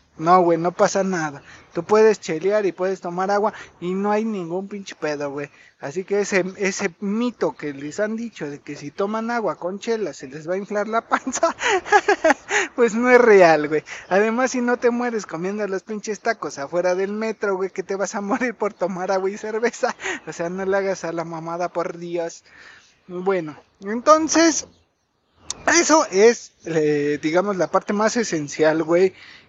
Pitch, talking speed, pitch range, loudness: 195 Hz, 185 wpm, 170-220 Hz, -21 LUFS